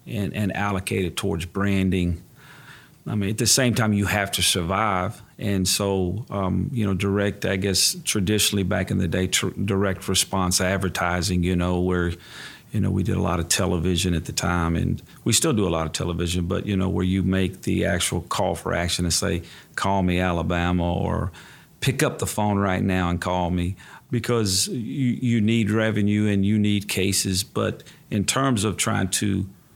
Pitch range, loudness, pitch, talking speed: 90-105 Hz, -23 LUFS, 95 Hz, 195 wpm